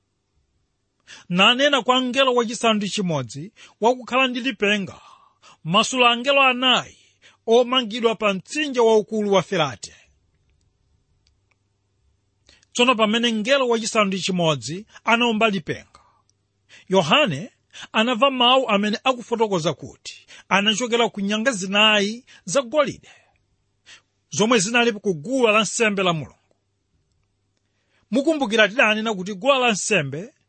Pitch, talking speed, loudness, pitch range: 210 Hz, 85 wpm, -19 LUFS, 145-240 Hz